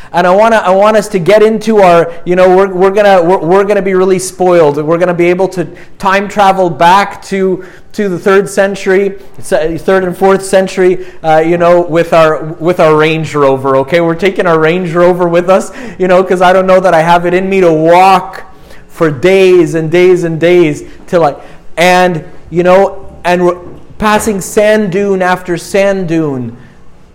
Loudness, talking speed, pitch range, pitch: -8 LUFS, 200 wpm, 170-195 Hz, 180 Hz